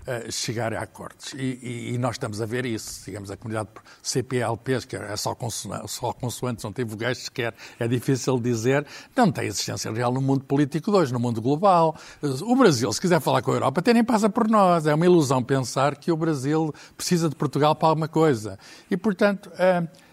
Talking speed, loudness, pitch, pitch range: 210 wpm, -24 LUFS, 135 Hz, 120-165 Hz